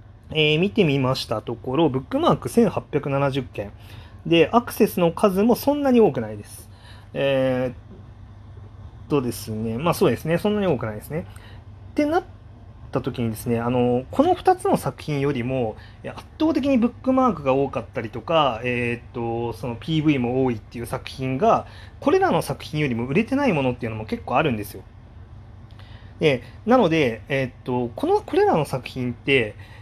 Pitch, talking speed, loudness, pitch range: 130 Hz, 330 characters per minute, -22 LUFS, 110-160 Hz